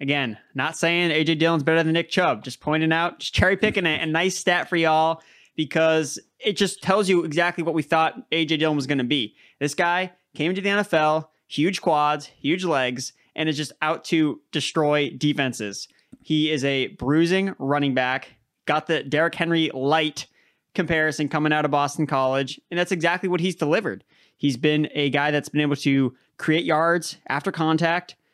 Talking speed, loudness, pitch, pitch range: 185 wpm, -22 LUFS, 155 Hz, 145-170 Hz